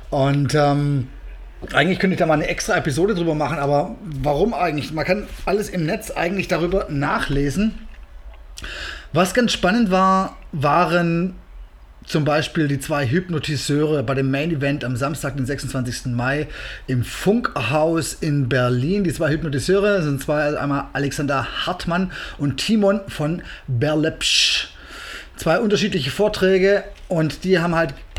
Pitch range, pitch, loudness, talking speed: 140-185 Hz, 150 Hz, -20 LUFS, 140 wpm